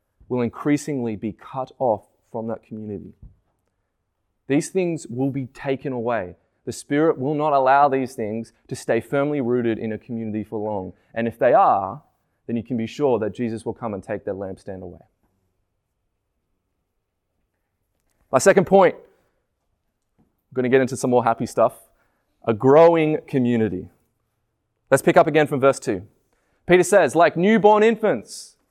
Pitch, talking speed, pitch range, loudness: 115 Hz, 155 wpm, 105-140 Hz, -20 LUFS